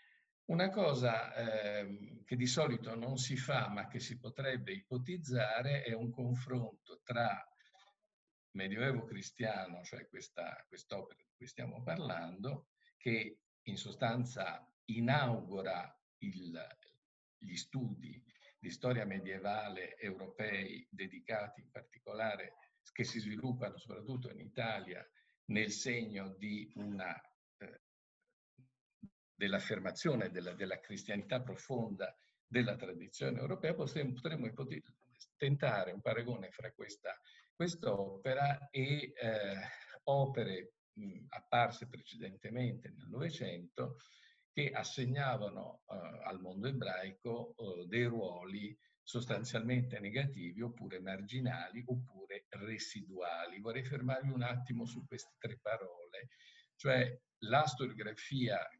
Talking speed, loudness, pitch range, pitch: 105 wpm, -40 LUFS, 110-140 Hz, 125 Hz